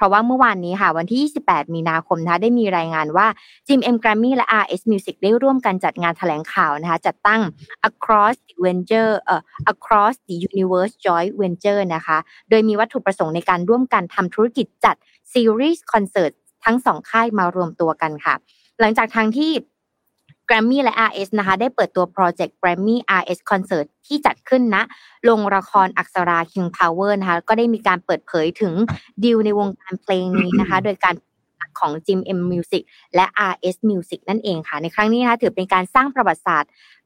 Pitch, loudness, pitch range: 195 Hz, -18 LUFS, 180-225 Hz